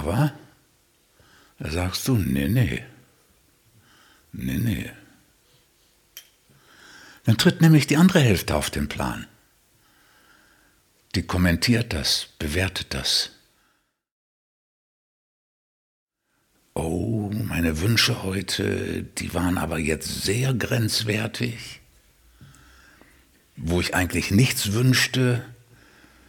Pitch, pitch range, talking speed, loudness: 105 Hz, 90-125 Hz, 85 wpm, -23 LUFS